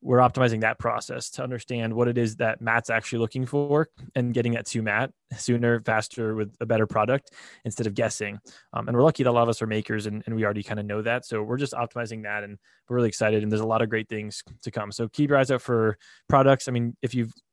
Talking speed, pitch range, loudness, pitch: 260 wpm, 110-125 Hz, -26 LUFS, 115 Hz